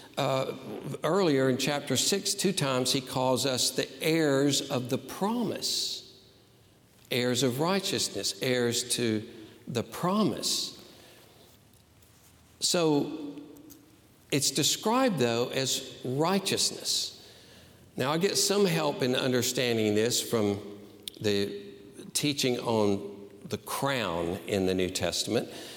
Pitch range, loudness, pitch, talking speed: 105-145 Hz, -28 LUFS, 125 Hz, 105 wpm